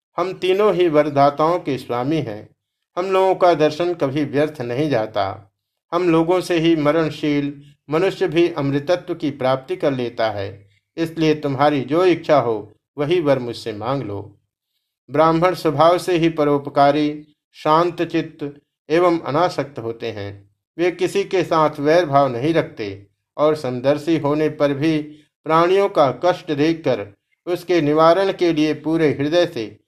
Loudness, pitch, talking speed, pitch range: -19 LUFS, 150 Hz, 145 wpm, 135-170 Hz